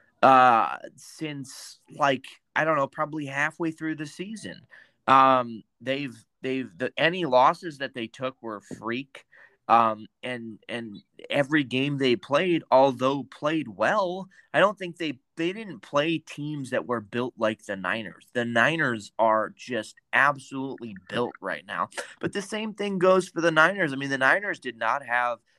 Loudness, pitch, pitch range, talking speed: -25 LUFS, 135 Hz, 120-160 Hz, 160 wpm